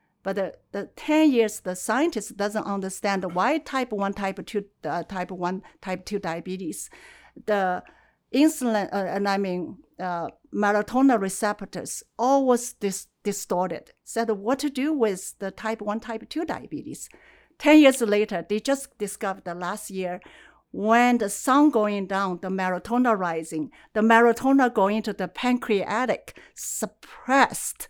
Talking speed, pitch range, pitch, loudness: 145 wpm, 190-235 Hz, 205 Hz, -24 LUFS